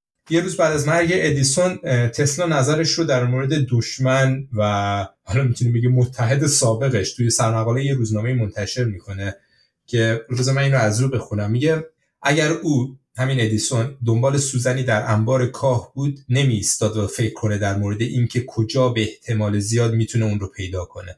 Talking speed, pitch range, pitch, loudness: 165 wpm, 110-135 Hz, 125 Hz, -20 LUFS